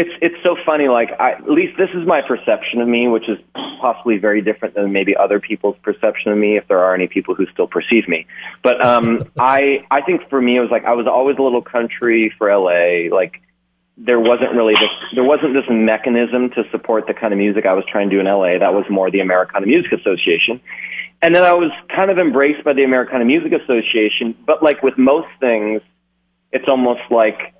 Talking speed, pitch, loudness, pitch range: 220 wpm, 120 Hz, -15 LUFS, 105-140 Hz